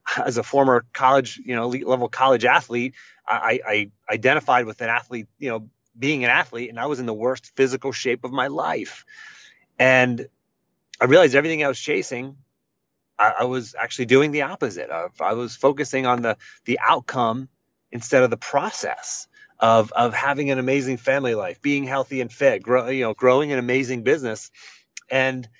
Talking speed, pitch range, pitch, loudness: 180 wpm, 120-135 Hz, 125 Hz, -21 LUFS